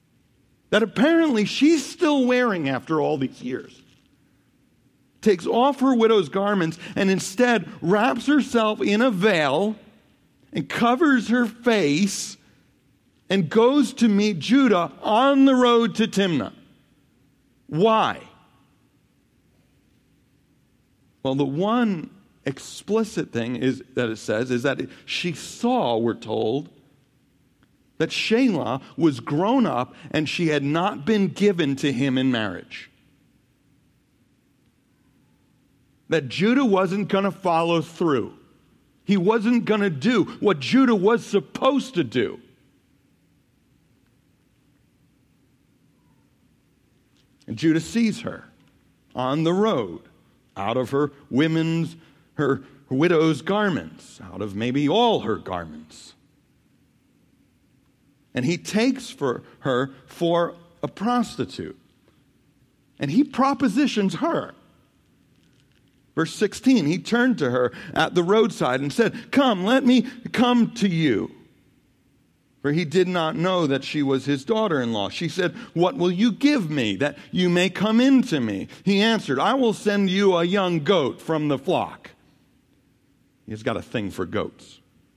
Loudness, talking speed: -22 LUFS, 125 wpm